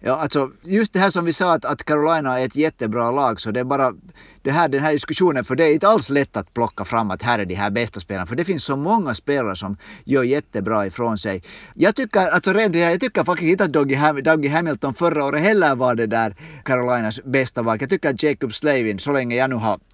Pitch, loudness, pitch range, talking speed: 140 Hz, -20 LUFS, 115-160 Hz, 245 wpm